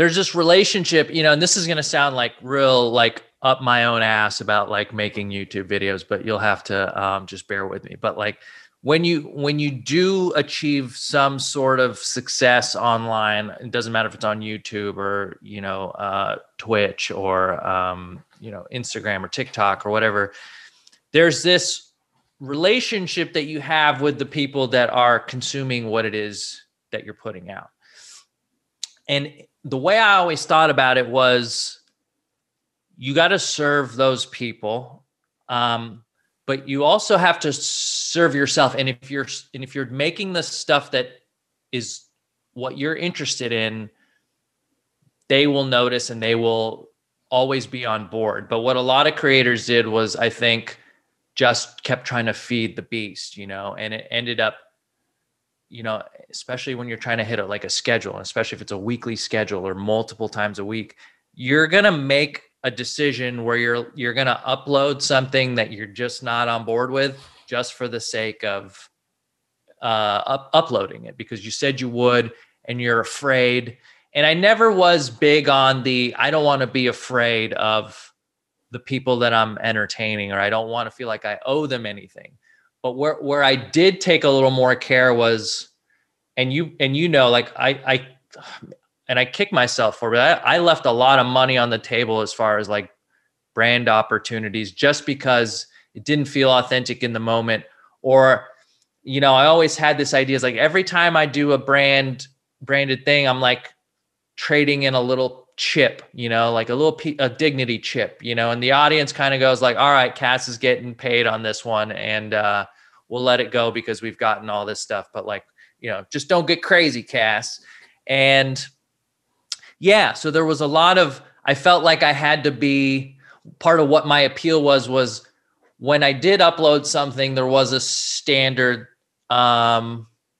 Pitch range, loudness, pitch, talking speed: 115-145 Hz, -19 LUFS, 130 Hz, 185 wpm